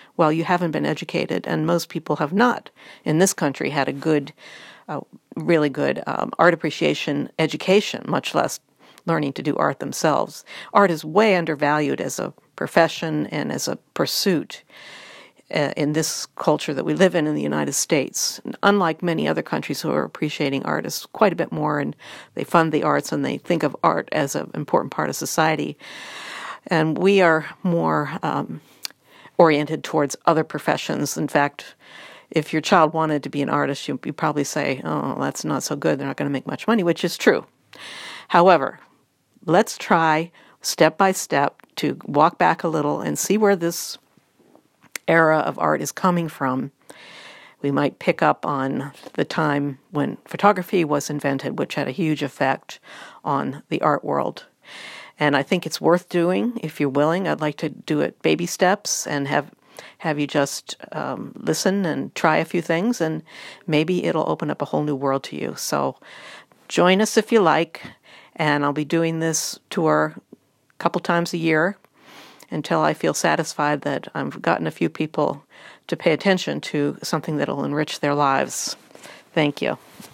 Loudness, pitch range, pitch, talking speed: -21 LUFS, 150-175 Hz, 160 Hz, 175 wpm